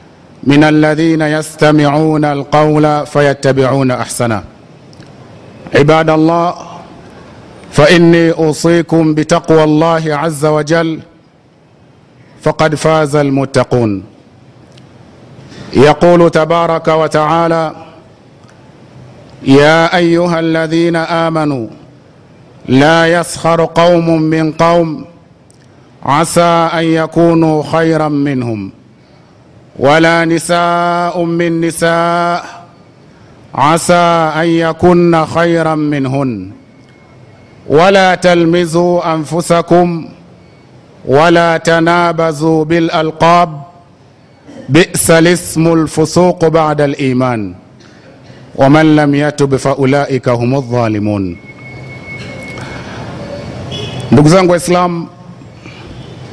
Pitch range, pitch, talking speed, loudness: 140-170 Hz, 160 Hz, 65 wpm, -10 LUFS